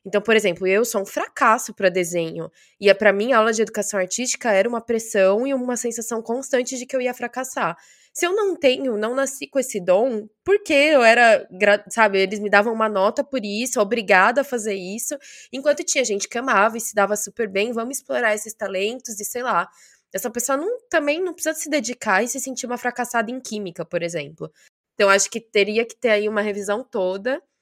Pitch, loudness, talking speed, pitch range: 230 Hz, -20 LUFS, 215 wpm, 205-260 Hz